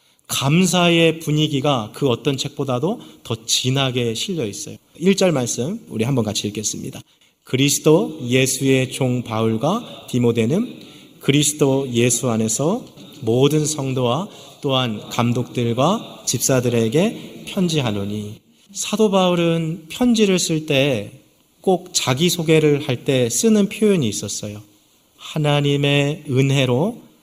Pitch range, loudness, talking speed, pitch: 120-165 Hz, -19 LUFS, 255 characters per minute, 135 Hz